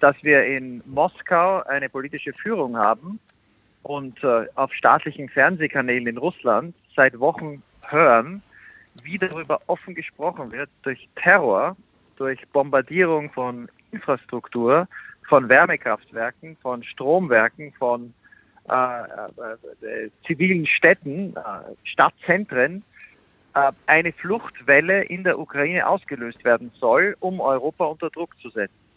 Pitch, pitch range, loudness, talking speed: 145 Hz, 125-175 Hz, -21 LUFS, 115 wpm